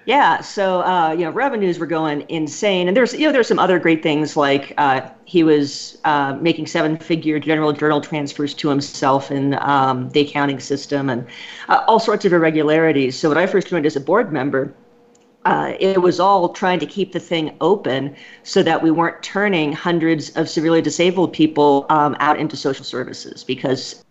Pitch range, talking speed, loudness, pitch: 145-180 Hz, 190 wpm, -18 LUFS, 155 Hz